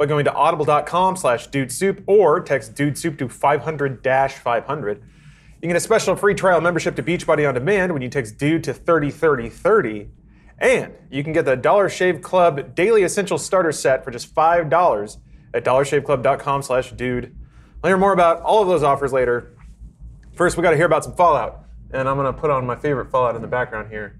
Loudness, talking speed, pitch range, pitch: -19 LUFS, 205 wpm, 130-170 Hz, 145 Hz